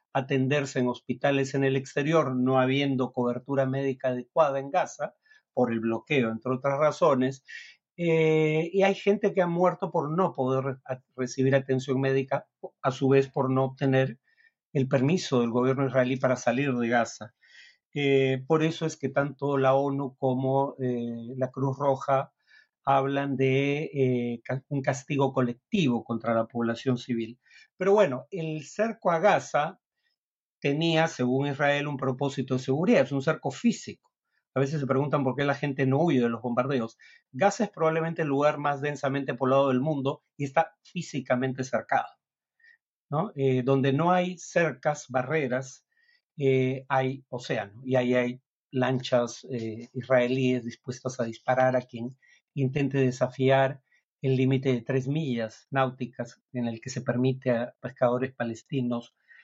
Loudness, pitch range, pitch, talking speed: -27 LUFS, 125-145 Hz, 135 Hz, 155 wpm